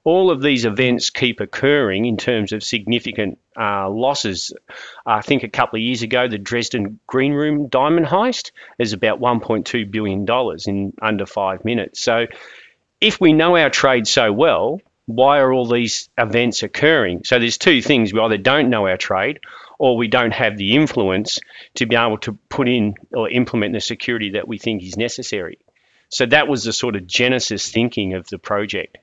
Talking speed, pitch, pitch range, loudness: 185 wpm, 120 Hz, 105-130 Hz, -18 LUFS